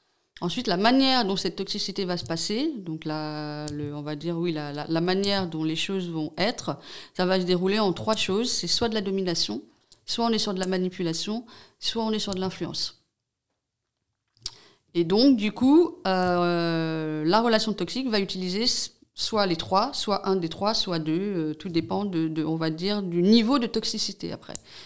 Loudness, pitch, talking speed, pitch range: -26 LUFS, 185 Hz, 200 wpm, 165-215 Hz